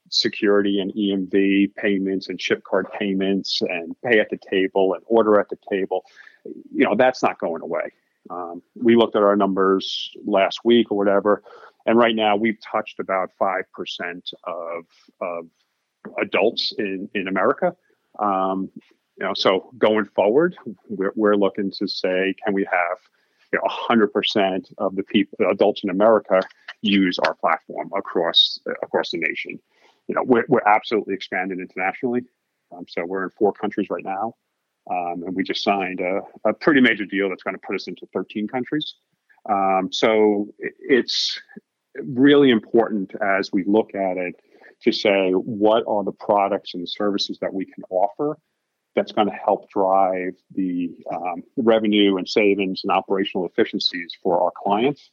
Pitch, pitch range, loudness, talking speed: 100 Hz, 95-110 Hz, -21 LUFS, 165 wpm